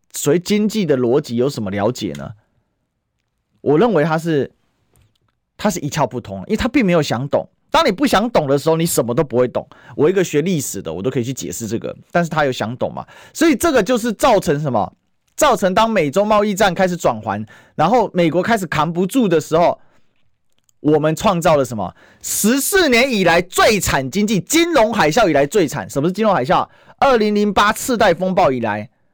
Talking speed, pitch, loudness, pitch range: 300 characters per minute, 170 Hz, -16 LUFS, 130-215 Hz